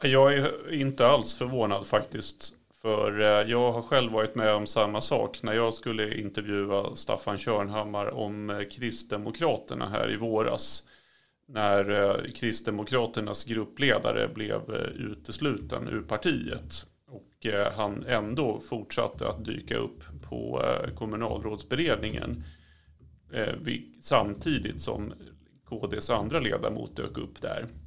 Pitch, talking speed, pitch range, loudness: 105 Hz, 110 wpm, 100-115 Hz, -29 LUFS